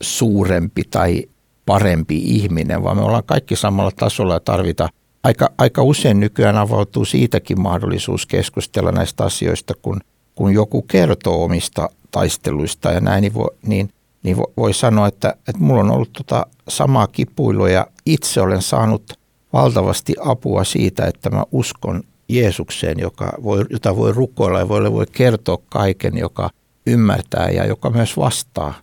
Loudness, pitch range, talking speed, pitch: -17 LUFS, 100-120 Hz, 150 wpm, 105 Hz